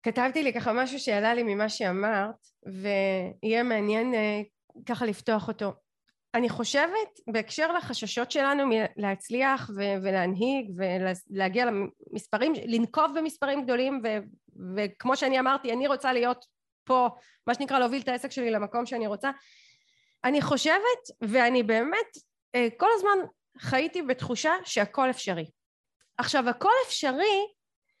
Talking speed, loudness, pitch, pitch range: 120 wpm, -27 LUFS, 245 Hz, 215-275 Hz